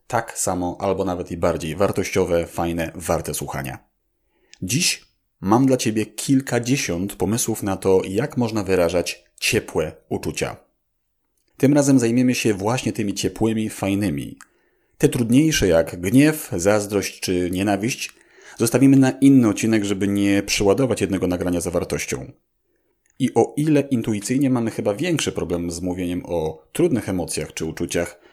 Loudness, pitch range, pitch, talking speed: -21 LUFS, 90-120 Hz, 100 Hz, 135 wpm